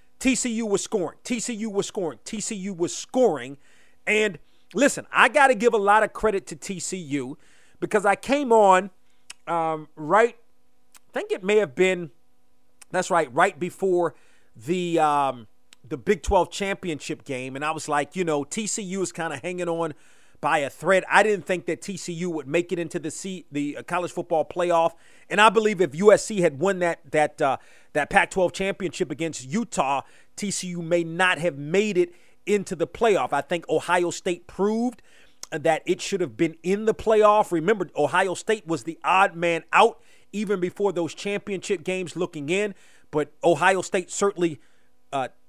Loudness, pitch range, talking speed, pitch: -24 LUFS, 165-200 Hz, 175 wpm, 180 Hz